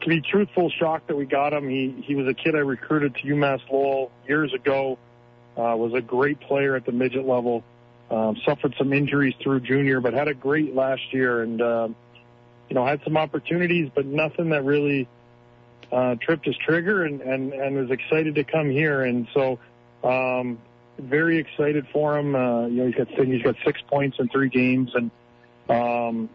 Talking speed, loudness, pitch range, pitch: 195 wpm, -23 LUFS, 120-145 Hz, 135 Hz